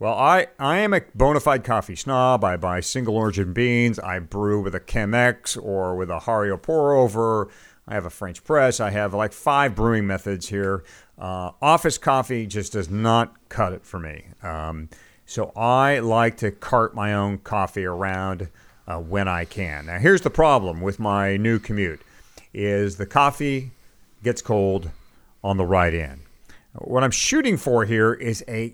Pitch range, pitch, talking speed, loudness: 95-120 Hz, 105 Hz, 175 wpm, -22 LUFS